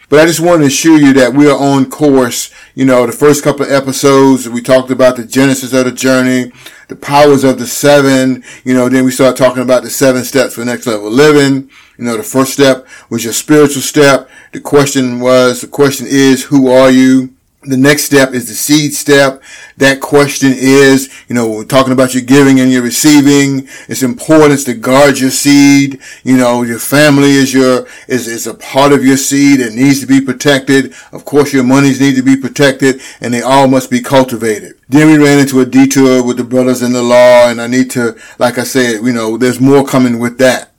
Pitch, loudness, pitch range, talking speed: 130 Hz, -8 LUFS, 125-140 Hz, 220 wpm